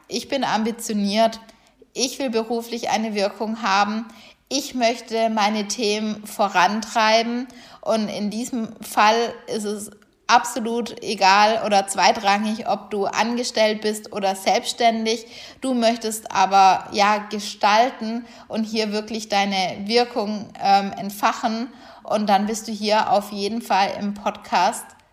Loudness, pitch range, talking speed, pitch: -21 LUFS, 205-235 Hz, 125 wpm, 220 Hz